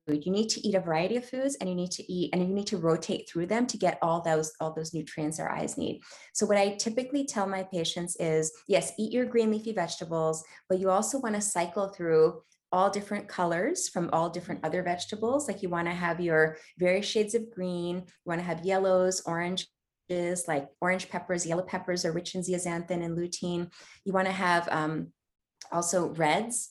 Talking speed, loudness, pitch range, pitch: 210 wpm, -30 LUFS, 170-200 Hz, 180 Hz